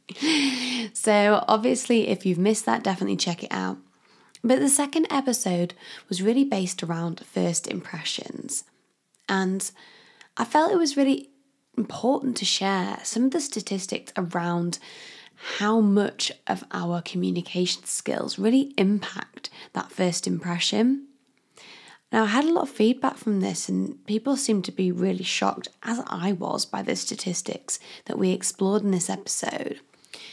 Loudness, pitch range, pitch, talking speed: -25 LUFS, 185-255 Hz, 210 Hz, 145 wpm